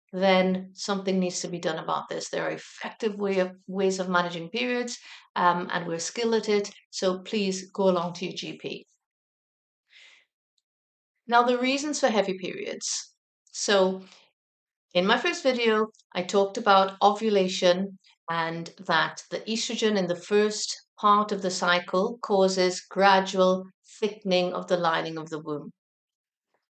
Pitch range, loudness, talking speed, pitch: 180-215 Hz, -26 LUFS, 145 wpm, 190 Hz